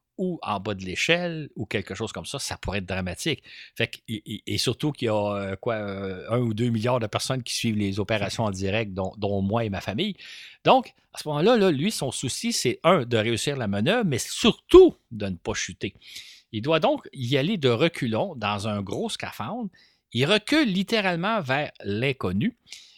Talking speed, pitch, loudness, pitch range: 205 wpm, 115 Hz, -25 LUFS, 105-165 Hz